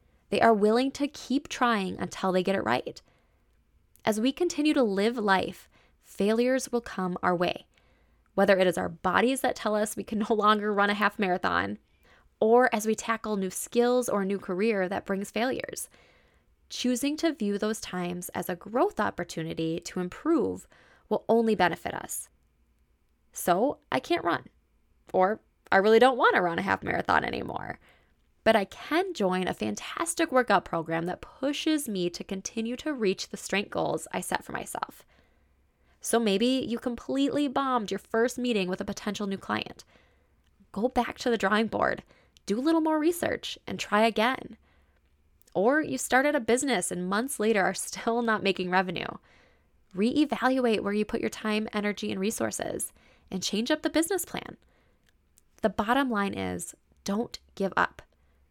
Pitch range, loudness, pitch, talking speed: 185-245 Hz, -28 LUFS, 210 Hz, 170 wpm